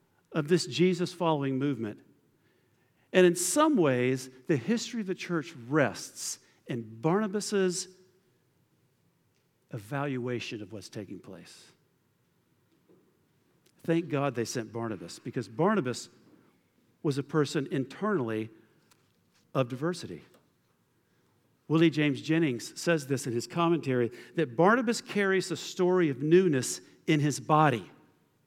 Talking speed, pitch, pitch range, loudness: 110 wpm, 150 Hz, 125-175 Hz, -29 LUFS